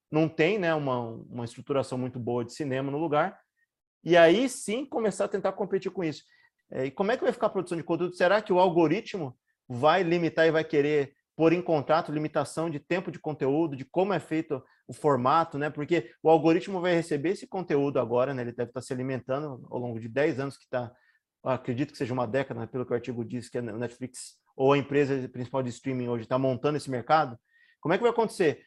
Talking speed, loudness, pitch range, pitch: 225 wpm, -28 LUFS, 130-170 Hz, 150 Hz